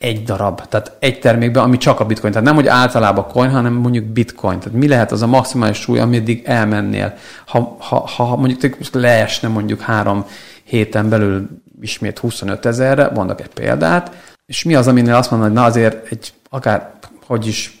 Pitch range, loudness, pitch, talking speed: 105-125 Hz, -15 LUFS, 115 Hz, 180 wpm